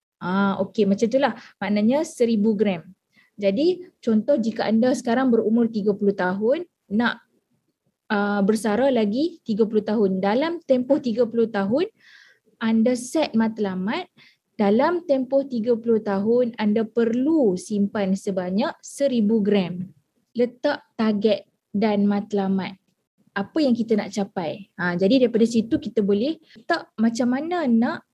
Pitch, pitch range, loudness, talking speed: 225 Hz, 205-250 Hz, -22 LUFS, 125 wpm